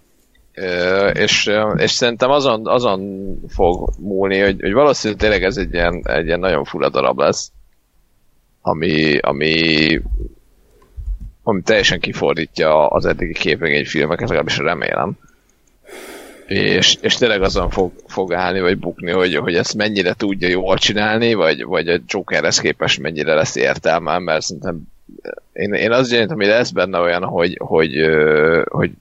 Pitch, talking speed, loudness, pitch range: 90 Hz, 145 wpm, -16 LUFS, 80-100 Hz